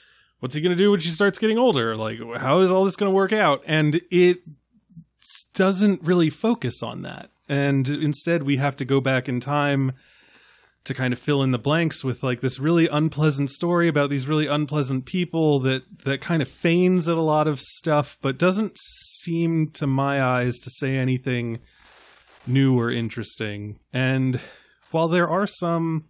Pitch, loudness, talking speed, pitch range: 150 Hz, -21 LUFS, 185 wpm, 130-170 Hz